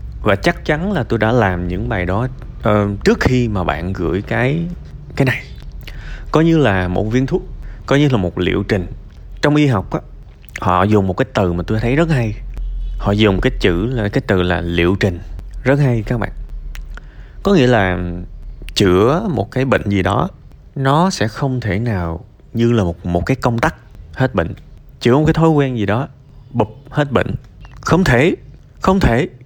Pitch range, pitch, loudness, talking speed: 95-130 Hz, 115 Hz, -16 LUFS, 195 wpm